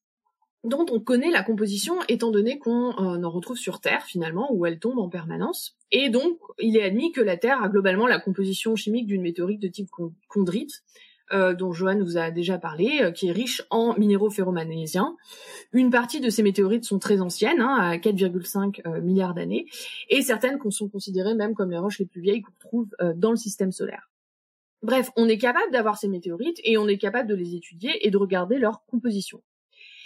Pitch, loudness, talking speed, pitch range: 210 Hz, -24 LUFS, 205 wpm, 190-245 Hz